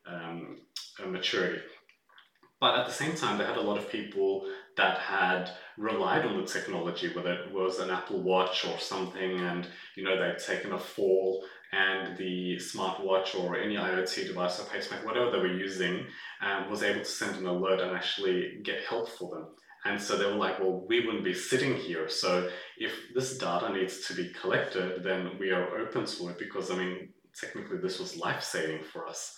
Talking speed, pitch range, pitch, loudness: 195 wpm, 90-95 Hz, 95 Hz, -31 LUFS